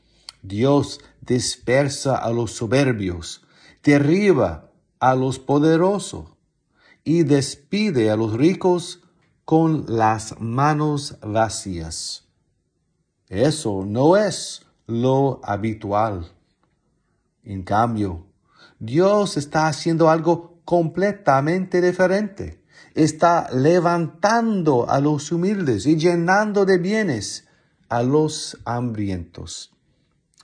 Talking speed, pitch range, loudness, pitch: 85 wpm, 115-170 Hz, -20 LUFS, 145 Hz